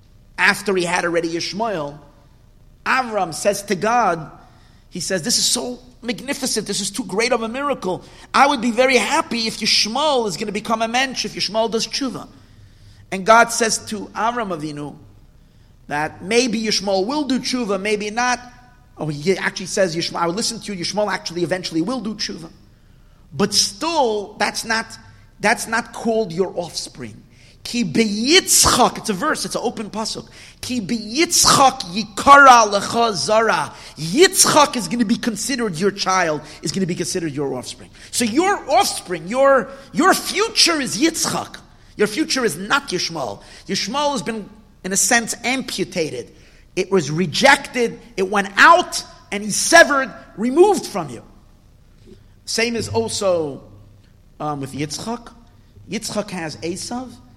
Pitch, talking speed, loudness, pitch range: 210 Hz, 155 wpm, -18 LUFS, 175-245 Hz